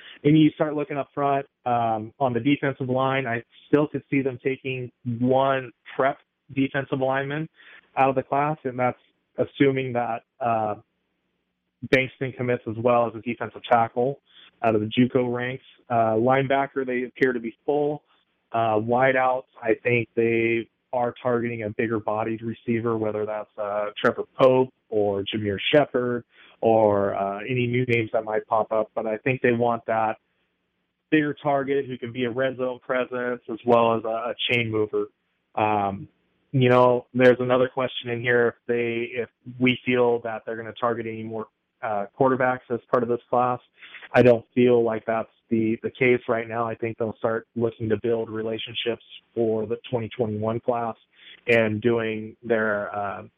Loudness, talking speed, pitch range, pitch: -24 LUFS, 175 wpm, 110-130 Hz, 120 Hz